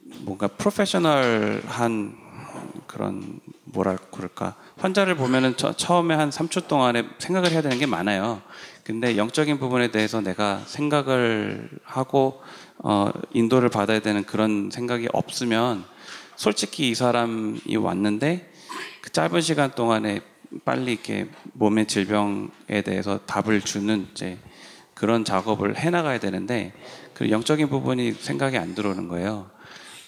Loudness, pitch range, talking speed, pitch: -24 LUFS, 105-140 Hz, 280 characters per minute, 115 Hz